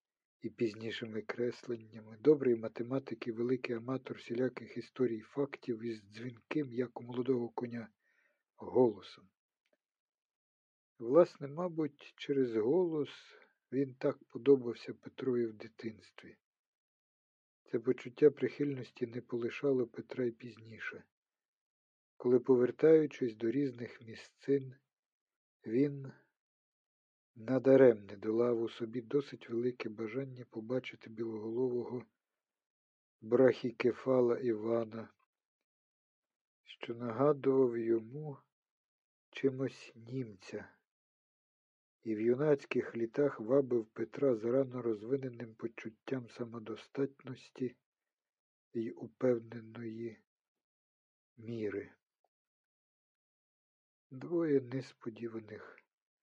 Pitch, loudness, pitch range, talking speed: 120 Hz, -35 LUFS, 115-135 Hz, 80 wpm